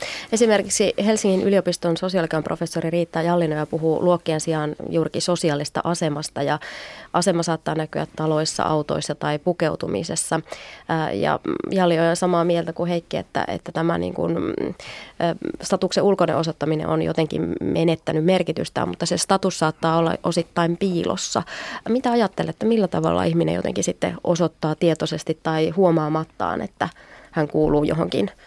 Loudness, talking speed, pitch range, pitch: -22 LUFS, 135 wpm, 155-180 Hz, 170 Hz